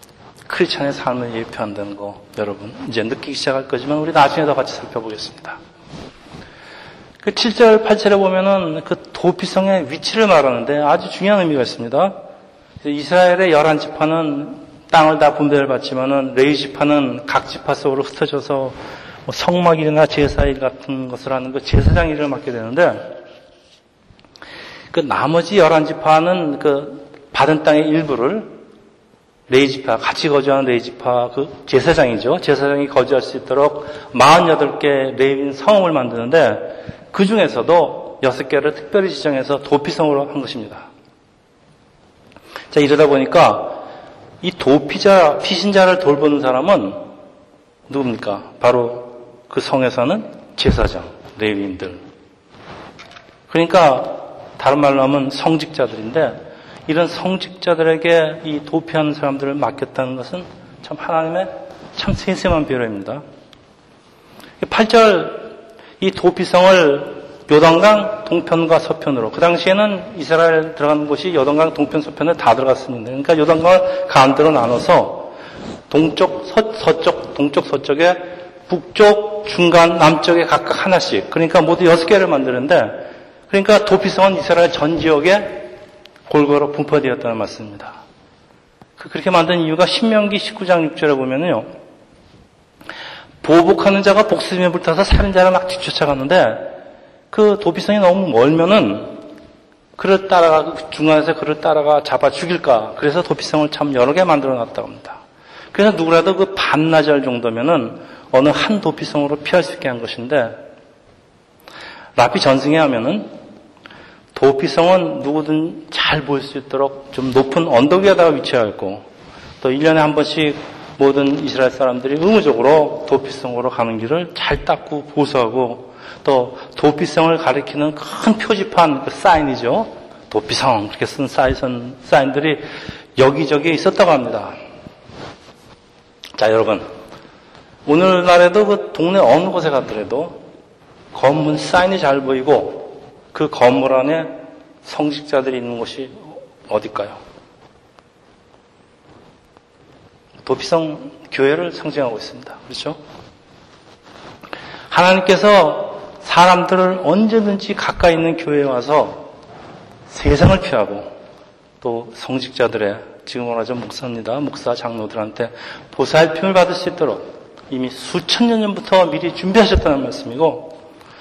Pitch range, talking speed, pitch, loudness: 135-180 Hz, 285 characters per minute, 155 Hz, -15 LUFS